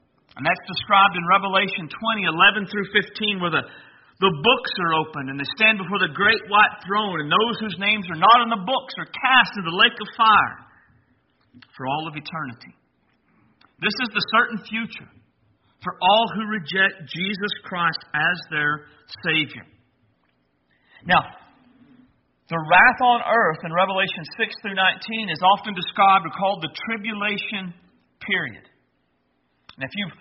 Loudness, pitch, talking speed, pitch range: -20 LUFS, 195 Hz, 155 wpm, 160-215 Hz